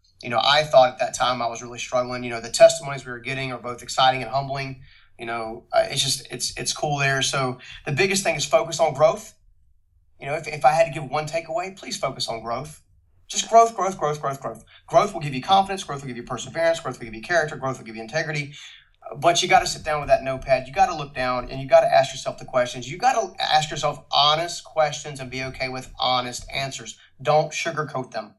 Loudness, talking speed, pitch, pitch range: -22 LUFS, 250 wpm, 135 Hz, 125-165 Hz